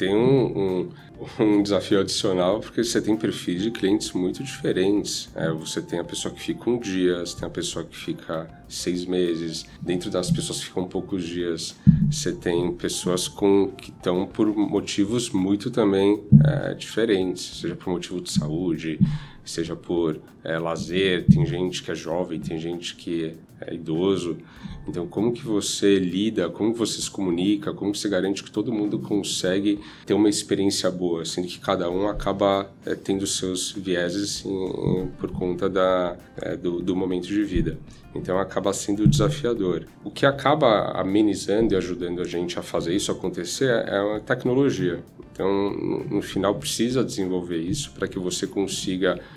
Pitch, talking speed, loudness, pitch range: 95 Hz, 170 wpm, -24 LUFS, 85-100 Hz